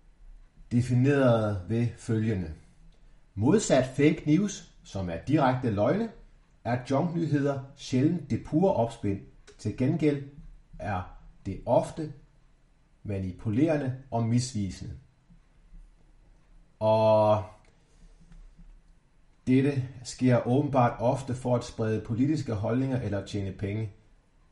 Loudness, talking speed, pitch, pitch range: -28 LUFS, 90 wpm, 125 Hz, 110-150 Hz